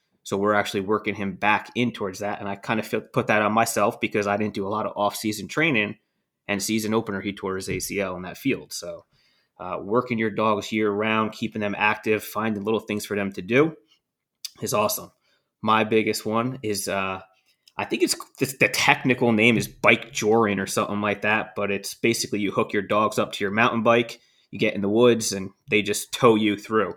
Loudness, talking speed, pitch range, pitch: -23 LUFS, 215 wpm, 100-115 Hz, 105 Hz